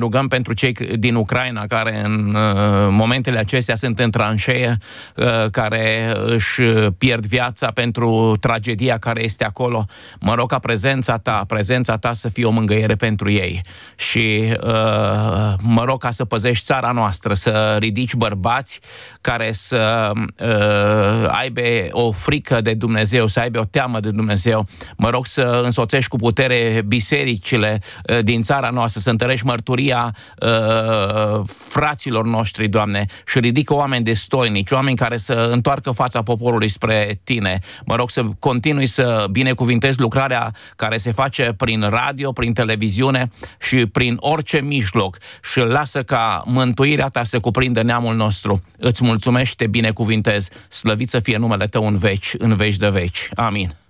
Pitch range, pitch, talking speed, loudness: 110-125 Hz, 115 Hz, 150 wpm, -18 LUFS